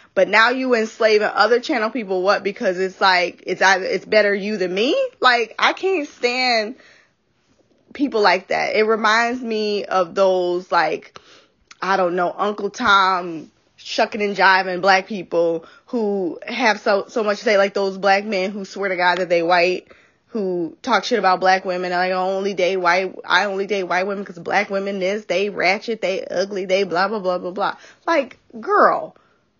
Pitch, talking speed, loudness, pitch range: 195 Hz, 185 wpm, -19 LUFS, 185-215 Hz